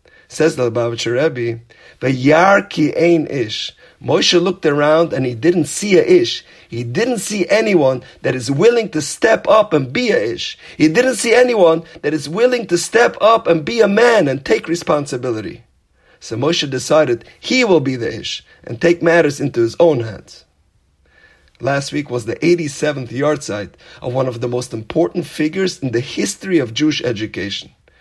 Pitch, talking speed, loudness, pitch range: 155 Hz, 180 wpm, -16 LUFS, 125-180 Hz